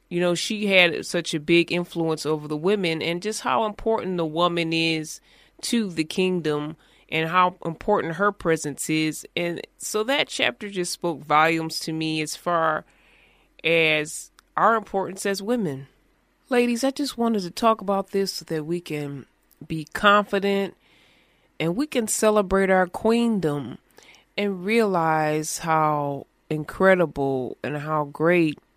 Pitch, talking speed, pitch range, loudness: 175 Hz, 145 wpm, 155-205 Hz, -23 LUFS